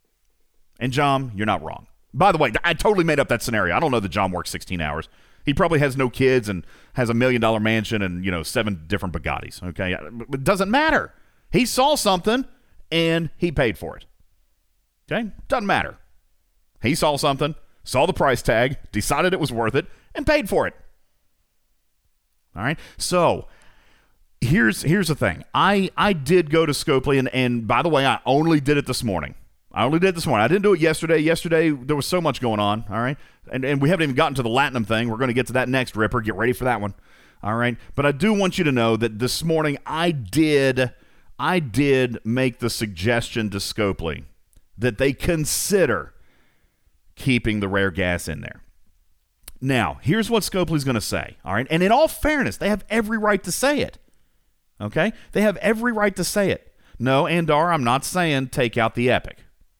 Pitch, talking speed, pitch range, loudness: 130 Hz, 205 wpm, 105-160 Hz, -21 LUFS